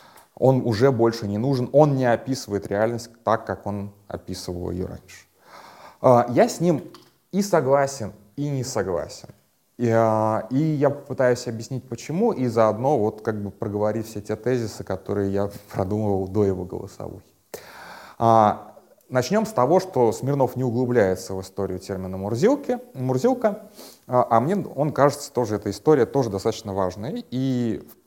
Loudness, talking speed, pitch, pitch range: -23 LUFS, 145 wpm, 115 Hz, 100-135 Hz